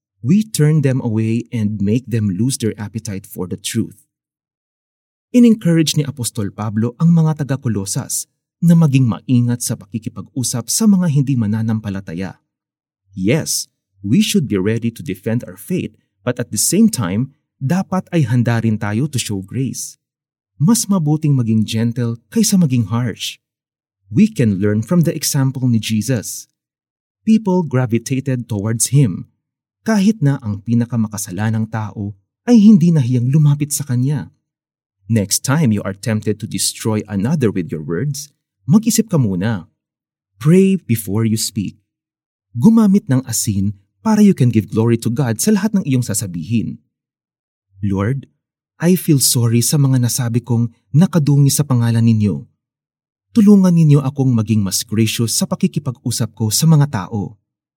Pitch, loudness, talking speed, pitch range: 120 Hz, -16 LUFS, 145 wpm, 110-150 Hz